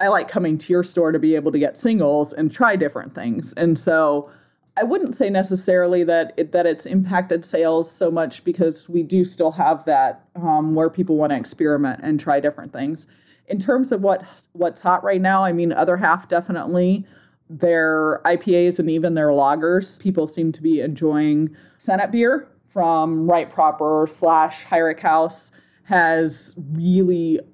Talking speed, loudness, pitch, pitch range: 175 wpm, -19 LUFS, 165 Hz, 155-180 Hz